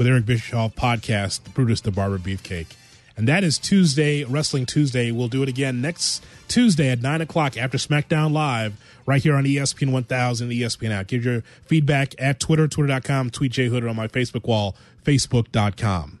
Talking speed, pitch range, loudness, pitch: 175 wpm, 115-145 Hz, -22 LUFS, 130 Hz